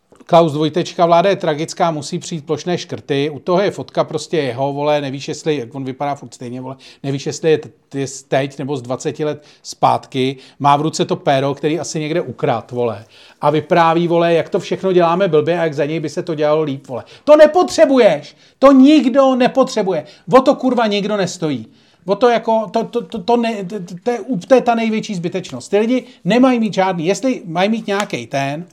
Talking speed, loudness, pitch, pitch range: 180 wpm, -16 LUFS, 165 Hz, 145-205 Hz